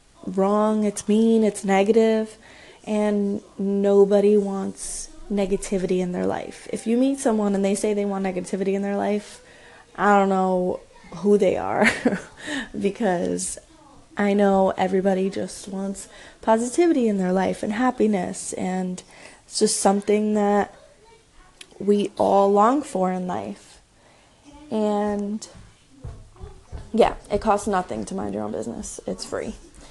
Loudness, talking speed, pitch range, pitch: -22 LUFS, 130 wpm, 195-215 Hz, 200 Hz